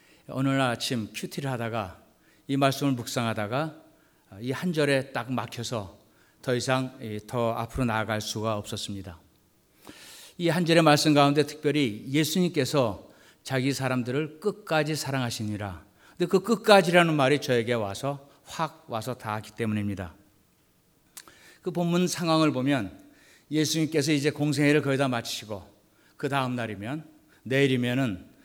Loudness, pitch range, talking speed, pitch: -26 LUFS, 115-150 Hz, 295 characters per minute, 130 Hz